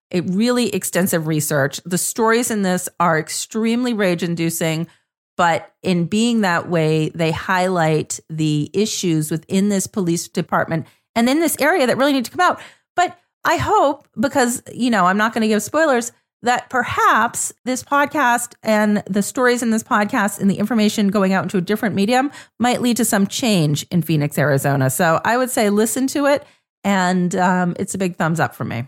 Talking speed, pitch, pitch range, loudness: 185 wpm, 200 Hz, 170-235 Hz, -18 LUFS